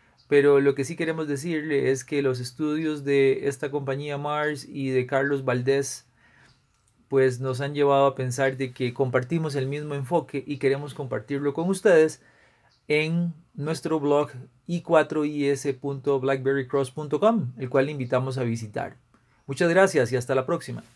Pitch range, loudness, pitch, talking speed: 130-150 Hz, -25 LUFS, 140 Hz, 145 wpm